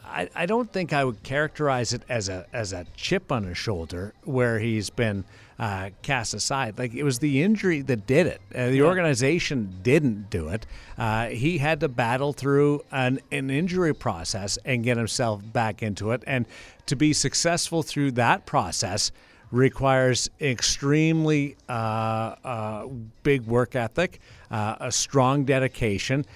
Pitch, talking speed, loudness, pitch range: 125 Hz, 155 wpm, -25 LUFS, 110-145 Hz